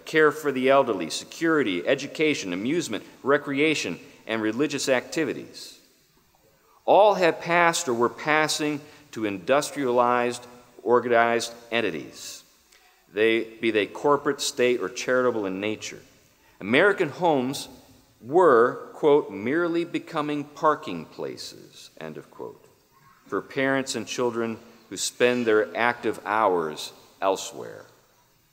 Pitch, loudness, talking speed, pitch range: 130 Hz, -24 LUFS, 105 wpm, 115-150 Hz